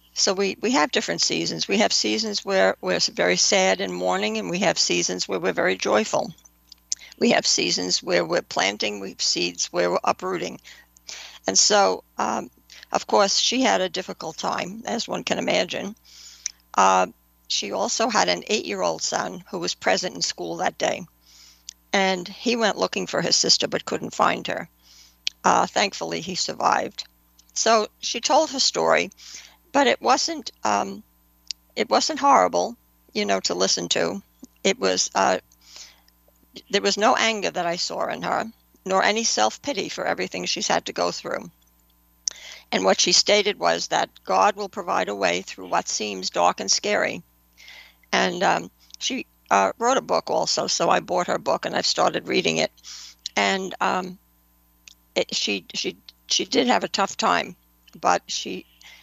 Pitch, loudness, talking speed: 90 Hz, -22 LUFS, 170 wpm